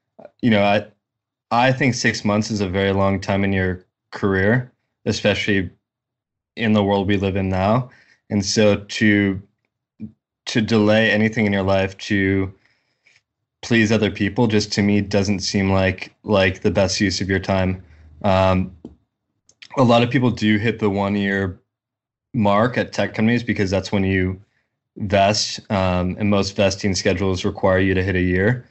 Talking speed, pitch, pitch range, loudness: 165 wpm, 100 Hz, 95-110 Hz, -19 LUFS